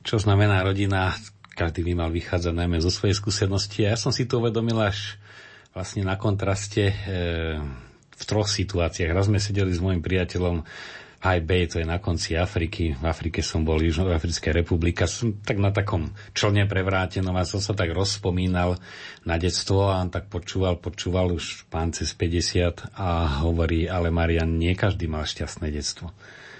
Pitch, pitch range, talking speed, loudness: 90 Hz, 85-100 Hz, 175 wpm, -25 LUFS